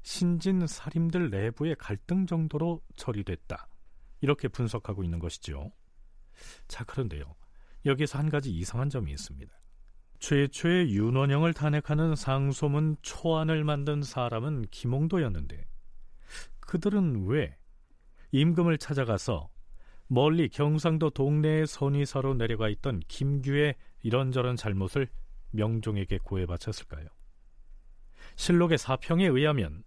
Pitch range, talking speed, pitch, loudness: 105-155 Hz, 275 characters per minute, 135 Hz, -29 LUFS